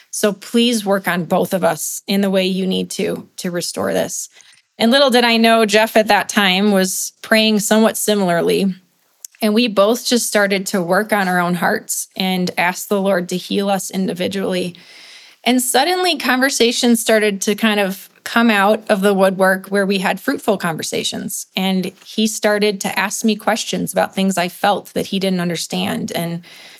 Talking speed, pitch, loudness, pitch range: 180 wpm, 200 Hz, -16 LUFS, 190-220 Hz